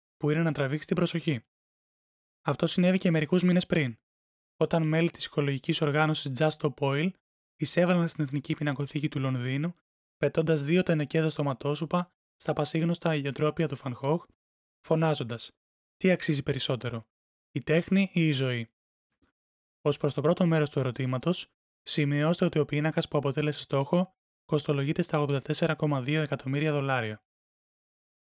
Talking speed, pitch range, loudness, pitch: 135 wpm, 140-165 Hz, -28 LUFS, 150 Hz